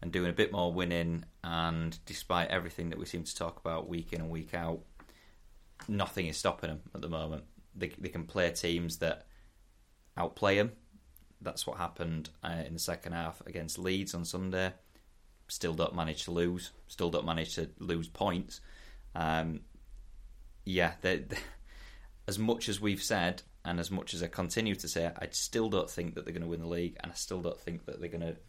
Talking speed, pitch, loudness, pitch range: 200 wpm, 85 Hz, -35 LUFS, 80-90 Hz